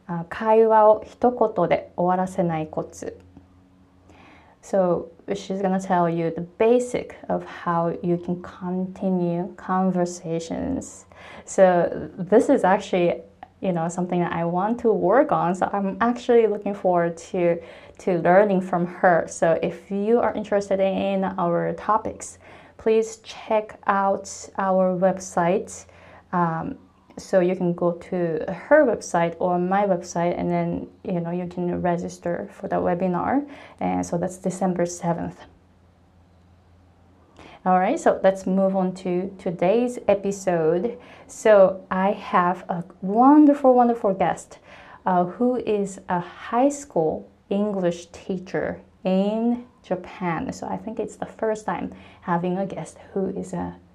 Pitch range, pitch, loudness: 170-200 Hz, 185 Hz, -23 LUFS